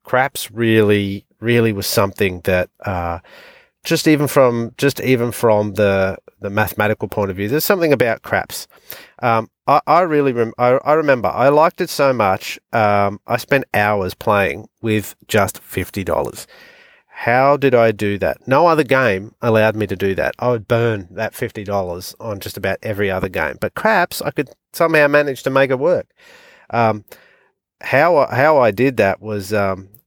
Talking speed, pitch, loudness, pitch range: 175 wpm, 115 Hz, -17 LUFS, 105-135 Hz